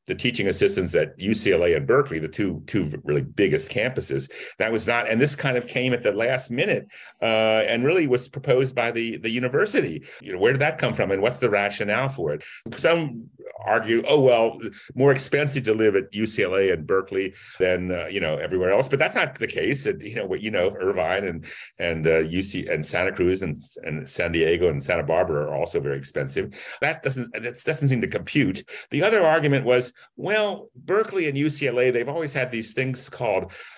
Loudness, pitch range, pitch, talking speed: -23 LUFS, 110-140 Hz, 125 Hz, 205 wpm